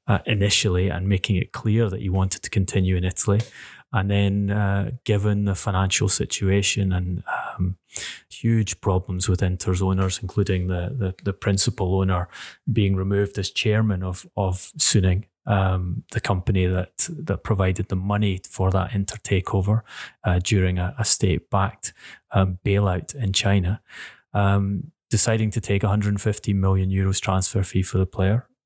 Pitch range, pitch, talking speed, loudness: 95-105 Hz, 100 Hz, 155 wpm, -22 LUFS